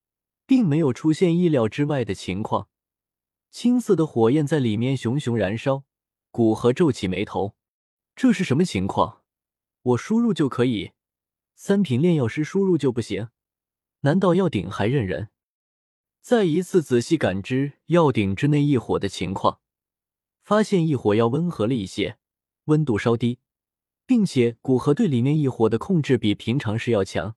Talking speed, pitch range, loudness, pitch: 235 characters per minute, 110-160 Hz, -22 LUFS, 130 Hz